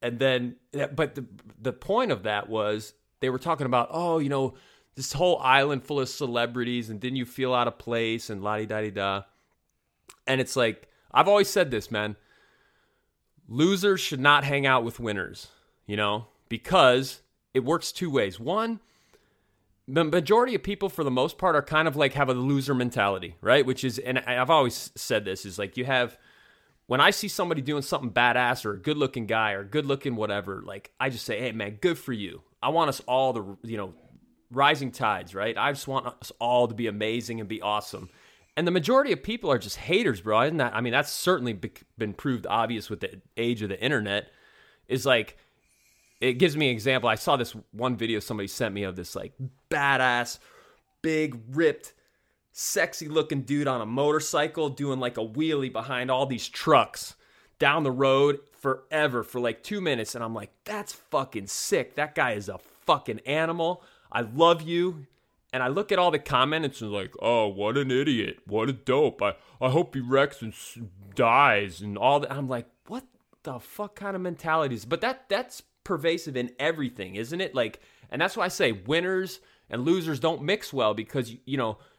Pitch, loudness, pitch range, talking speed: 130 Hz, -26 LUFS, 115-155 Hz, 195 wpm